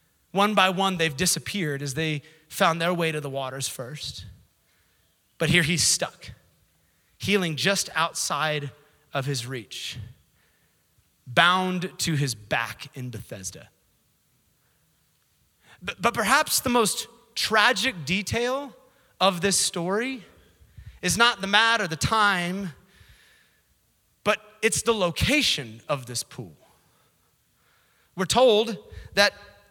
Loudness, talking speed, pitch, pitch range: -24 LUFS, 115 wpm, 165 Hz, 130-205 Hz